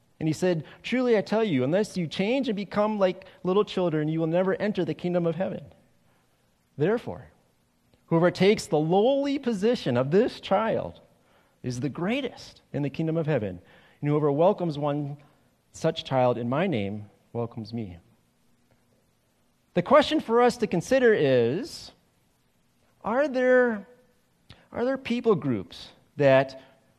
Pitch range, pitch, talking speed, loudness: 135-215 Hz, 175 Hz, 145 wpm, -25 LUFS